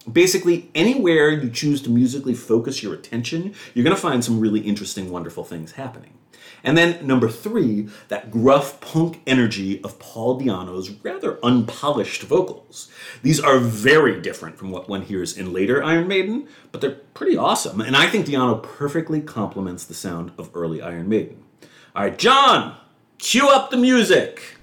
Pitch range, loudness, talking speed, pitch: 105-165 Hz, -19 LUFS, 165 wpm, 125 Hz